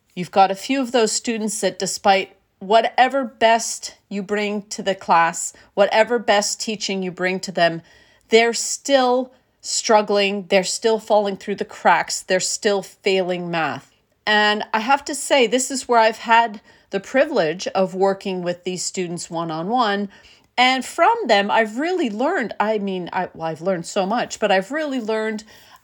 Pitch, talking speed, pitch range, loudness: 210 Hz, 170 wpm, 190-230 Hz, -20 LUFS